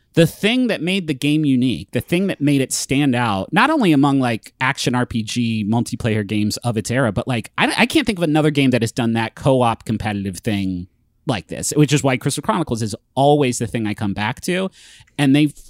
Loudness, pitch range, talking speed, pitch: -18 LUFS, 115-145 Hz, 225 wpm, 125 Hz